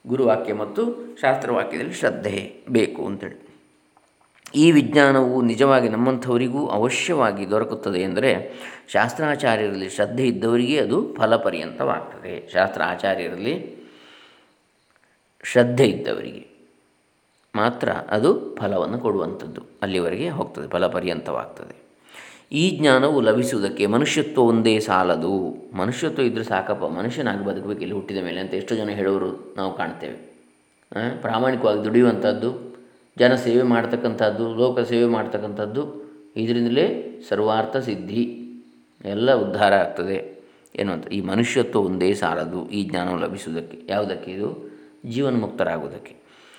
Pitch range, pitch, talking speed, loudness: 90-125 Hz, 110 Hz, 95 wpm, -22 LUFS